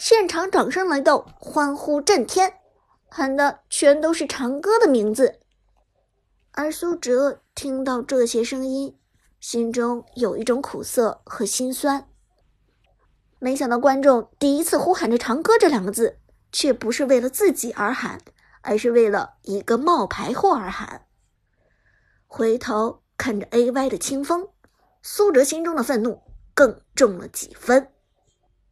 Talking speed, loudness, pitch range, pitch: 205 characters per minute, -21 LUFS, 240-315 Hz, 270 Hz